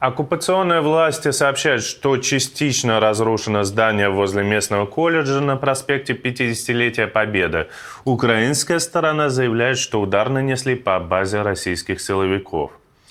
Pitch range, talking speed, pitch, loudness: 110-140 Hz, 110 wpm, 125 Hz, -19 LUFS